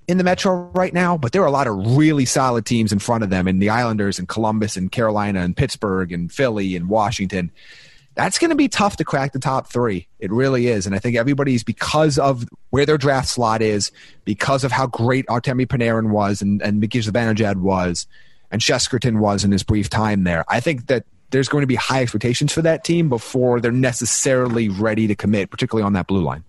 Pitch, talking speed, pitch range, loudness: 120 Hz, 220 wpm, 105-135 Hz, -19 LUFS